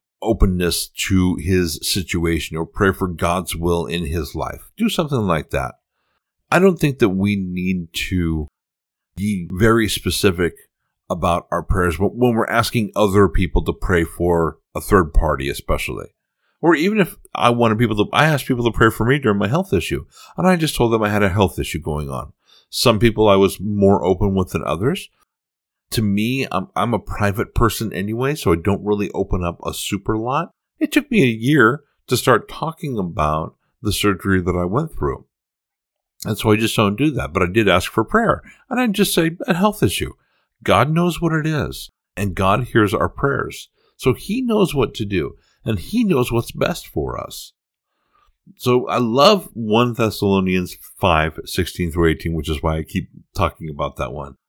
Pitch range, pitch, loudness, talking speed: 90-125 Hz, 105 Hz, -19 LUFS, 190 wpm